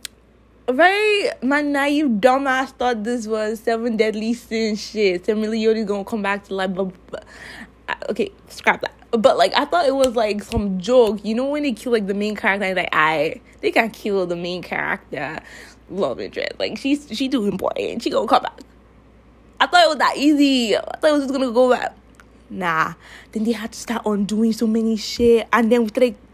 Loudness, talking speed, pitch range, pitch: -20 LUFS, 205 wpm, 215-260 Hz, 230 Hz